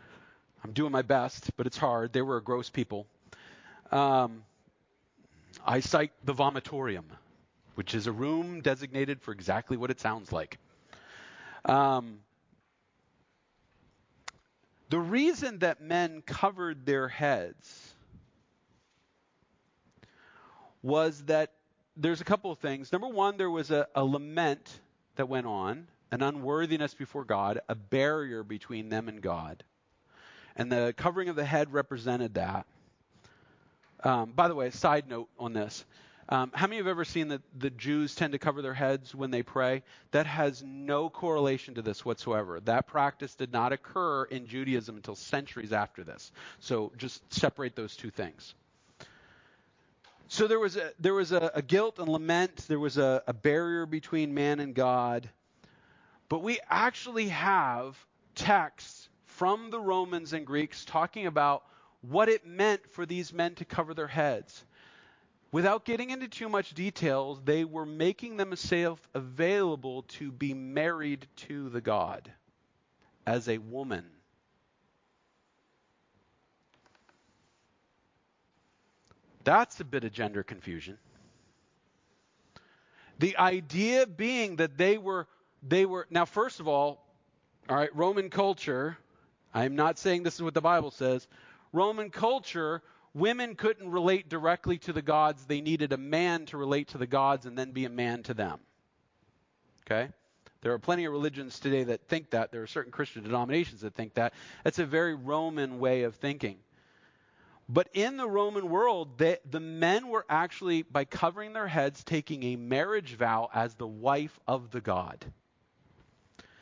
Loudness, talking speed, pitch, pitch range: -31 LUFS, 150 wpm, 145 Hz, 125-170 Hz